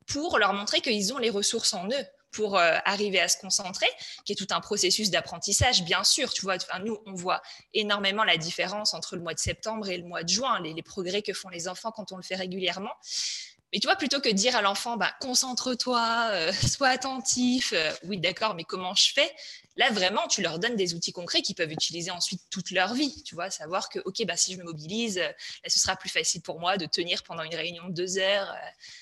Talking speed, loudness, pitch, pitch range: 240 wpm, -27 LUFS, 195 Hz, 180-230 Hz